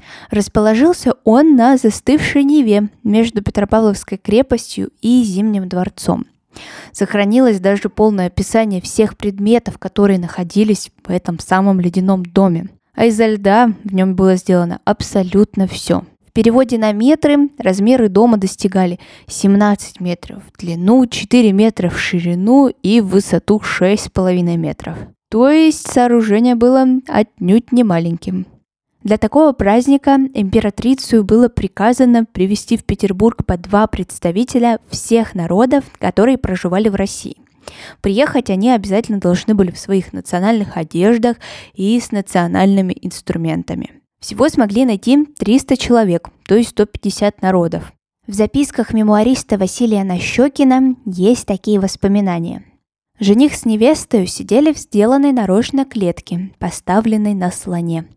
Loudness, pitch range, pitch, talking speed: -14 LUFS, 190-240 Hz, 210 Hz, 125 wpm